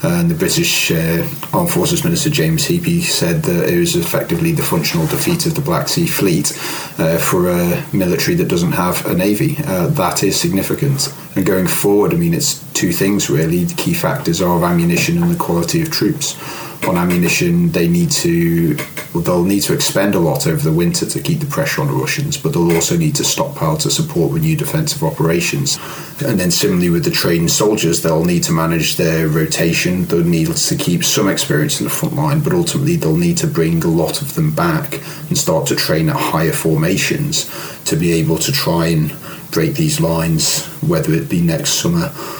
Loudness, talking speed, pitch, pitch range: -15 LUFS, 200 wpm, 160 Hz, 145-170 Hz